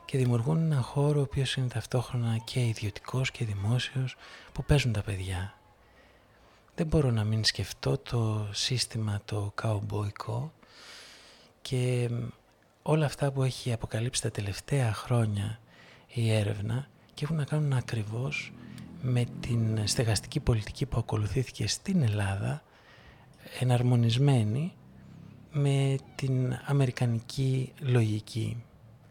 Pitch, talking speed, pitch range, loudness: 120 Hz, 110 wpm, 110-135 Hz, -30 LUFS